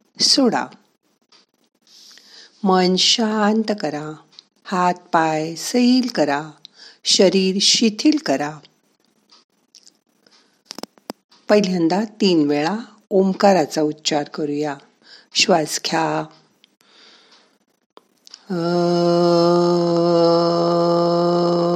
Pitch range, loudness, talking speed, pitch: 160-200 Hz, -18 LUFS, 55 wpm, 175 Hz